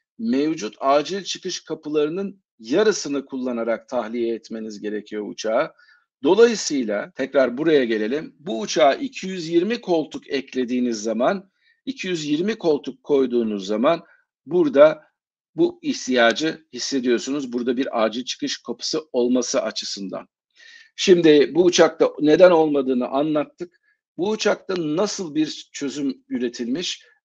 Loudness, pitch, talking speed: -21 LUFS, 165 Hz, 105 wpm